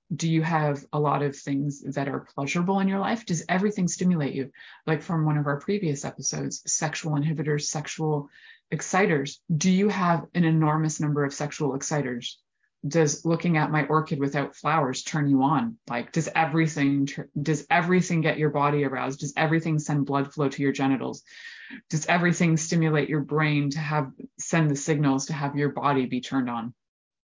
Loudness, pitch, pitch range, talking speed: -25 LUFS, 150 Hz, 140-165 Hz, 180 wpm